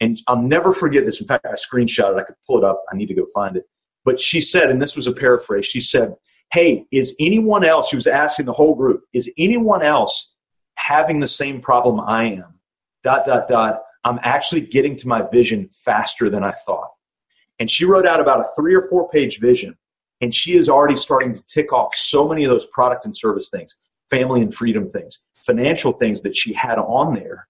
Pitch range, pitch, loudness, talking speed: 120-160 Hz, 135 Hz, -17 LUFS, 220 wpm